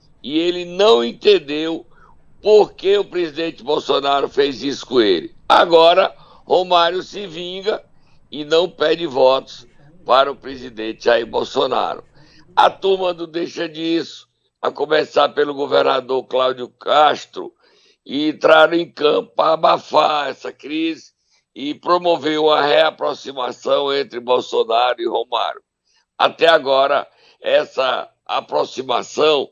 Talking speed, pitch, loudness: 115 wpm, 165 Hz, -17 LUFS